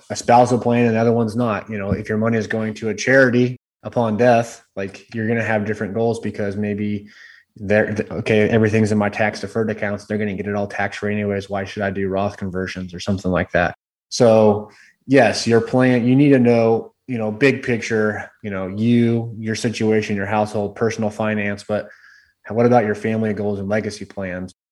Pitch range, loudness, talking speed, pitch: 100-115 Hz, -19 LUFS, 210 wpm, 105 Hz